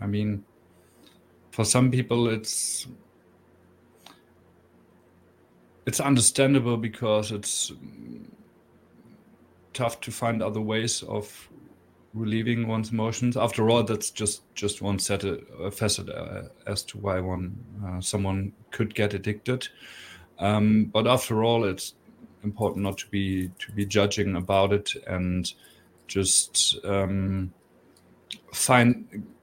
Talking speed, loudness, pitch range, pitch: 115 wpm, -26 LUFS, 95-115 Hz, 105 Hz